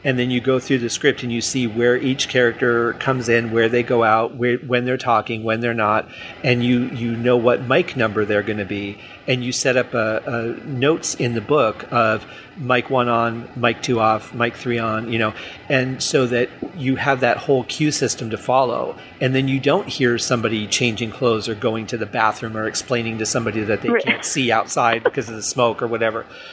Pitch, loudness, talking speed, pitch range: 120 Hz, -19 LUFS, 220 wpm, 115-130 Hz